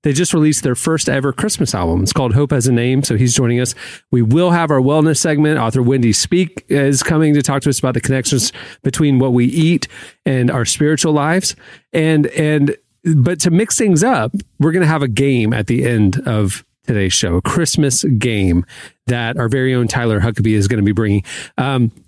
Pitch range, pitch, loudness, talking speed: 120-155 Hz, 130 Hz, -15 LUFS, 210 wpm